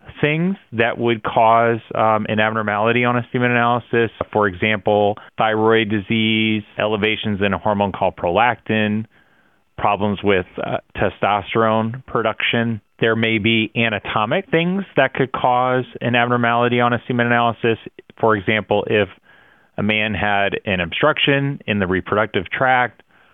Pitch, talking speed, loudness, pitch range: 115 Hz, 135 wpm, -18 LUFS, 105-120 Hz